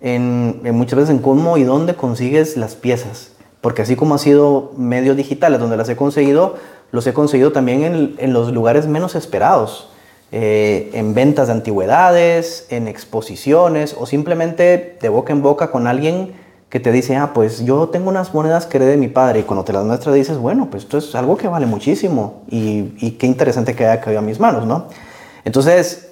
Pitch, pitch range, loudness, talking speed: 135 Hz, 115-150 Hz, -15 LUFS, 200 wpm